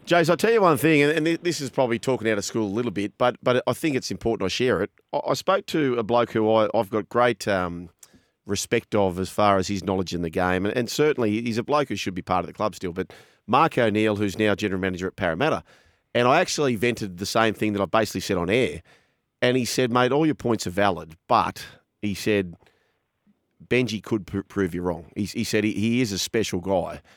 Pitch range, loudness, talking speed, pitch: 100-125 Hz, -23 LUFS, 245 wpm, 110 Hz